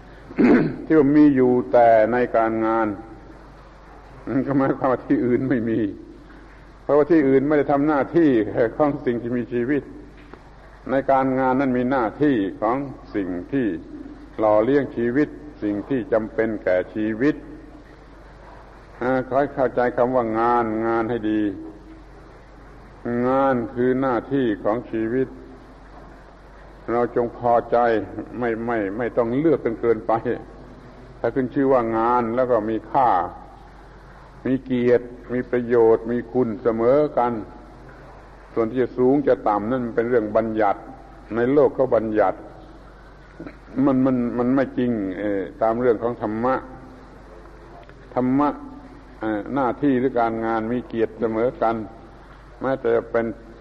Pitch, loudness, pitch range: 120 Hz, -21 LUFS, 115-130 Hz